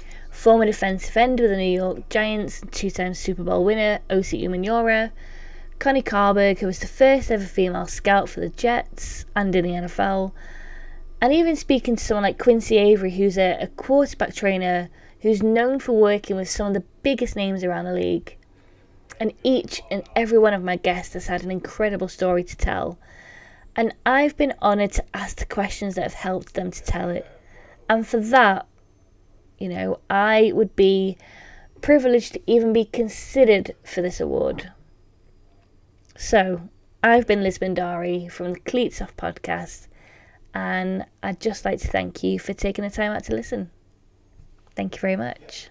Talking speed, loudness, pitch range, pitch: 170 wpm, -22 LUFS, 175-220 Hz, 195 Hz